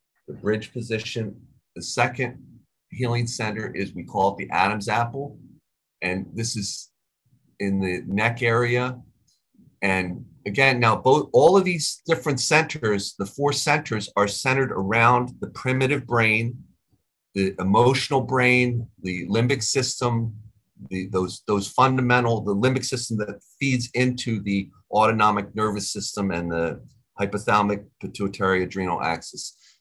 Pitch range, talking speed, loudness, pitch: 100-125 Hz, 130 wpm, -23 LUFS, 110 Hz